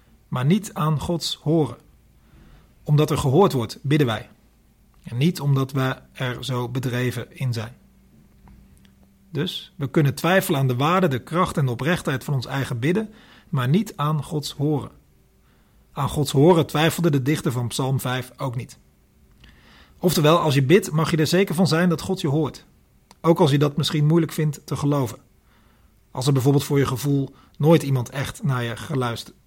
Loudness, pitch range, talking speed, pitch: -22 LUFS, 125-160 Hz, 175 wpm, 140 Hz